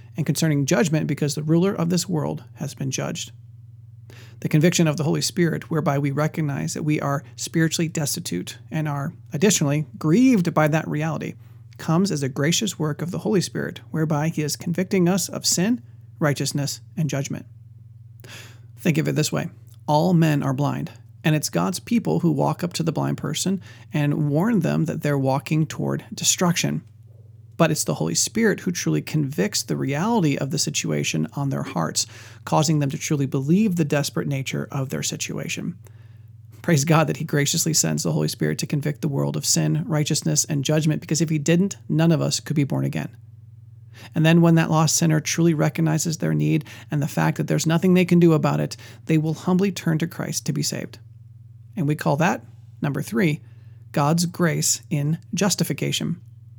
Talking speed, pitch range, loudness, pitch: 185 wpm, 115-165 Hz, -22 LUFS, 150 Hz